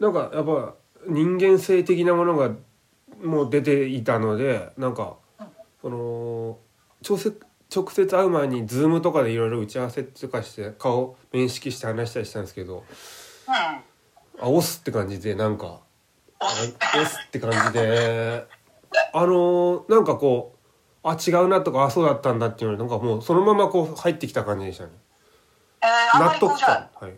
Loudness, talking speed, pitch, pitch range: -22 LUFS, 310 characters per minute, 135 Hz, 115-175 Hz